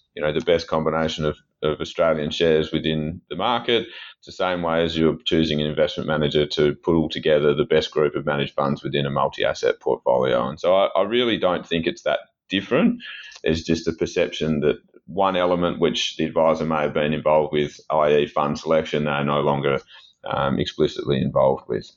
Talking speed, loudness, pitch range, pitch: 195 wpm, -22 LUFS, 75-85 Hz, 80 Hz